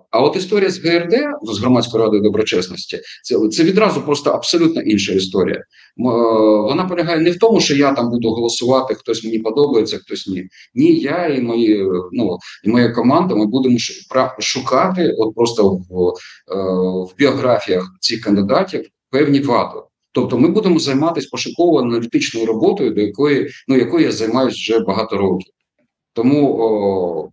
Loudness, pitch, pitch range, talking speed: -16 LUFS, 120 Hz, 105-155 Hz, 150 wpm